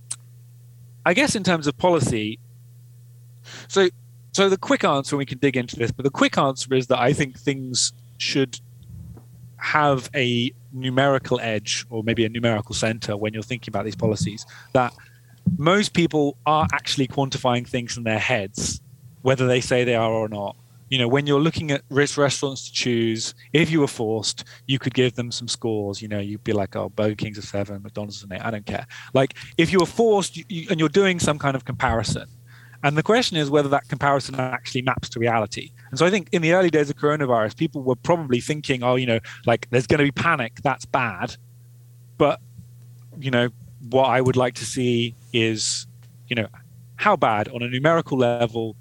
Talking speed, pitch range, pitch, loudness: 200 wpm, 120-140 Hz, 125 Hz, -22 LUFS